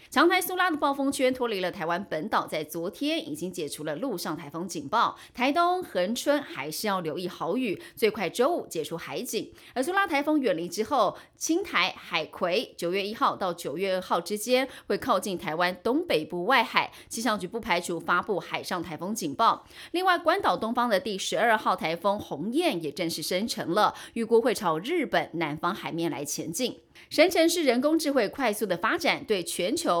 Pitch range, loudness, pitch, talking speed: 175-285 Hz, -27 LUFS, 210 Hz, 290 characters per minute